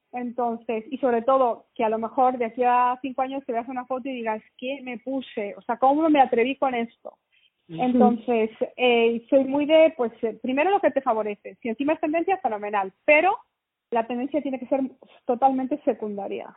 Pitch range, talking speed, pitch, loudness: 230-275 Hz, 190 wpm, 250 Hz, -24 LUFS